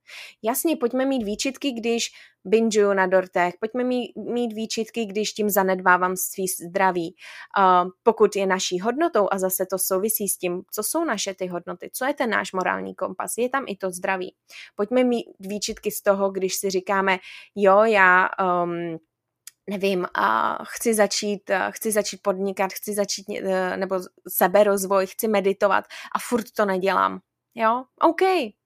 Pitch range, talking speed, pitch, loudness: 185-225 Hz, 155 wpm, 200 Hz, -23 LUFS